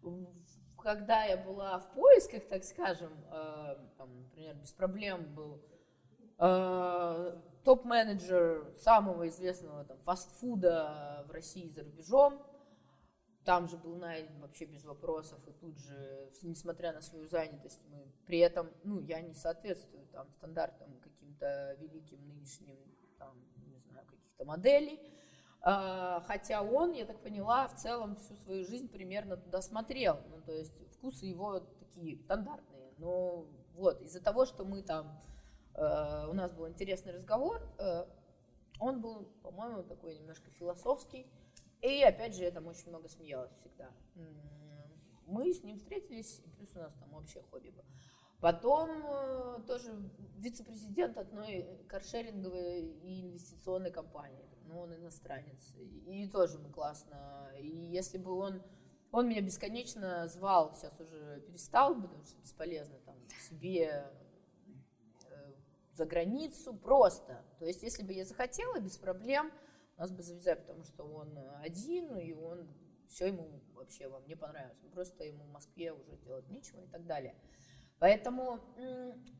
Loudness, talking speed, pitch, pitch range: -36 LUFS, 135 wpm, 175 Hz, 155-205 Hz